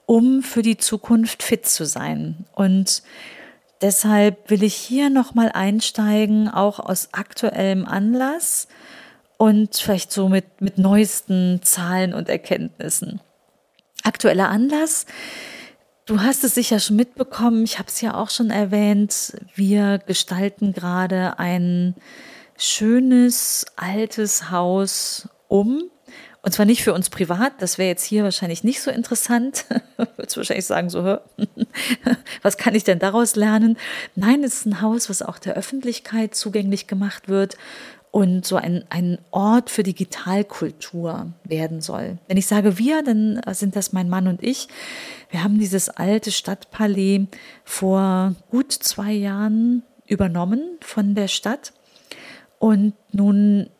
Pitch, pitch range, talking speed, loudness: 210 Hz, 195-230 Hz, 135 wpm, -20 LUFS